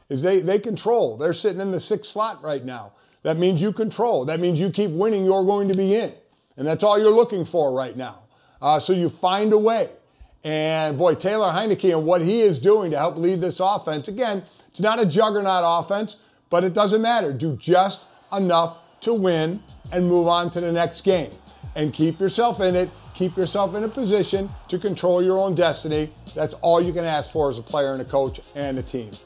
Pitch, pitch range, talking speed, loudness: 180 Hz, 160-205 Hz, 215 wpm, -21 LUFS